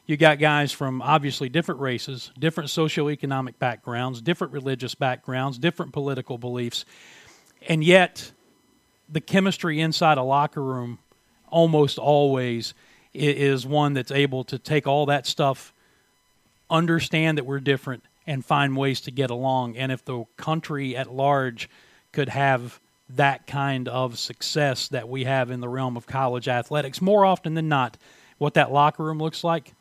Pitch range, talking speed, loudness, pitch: 130-155 Hz, 155 wpm, -23 LUFS, 140 Hz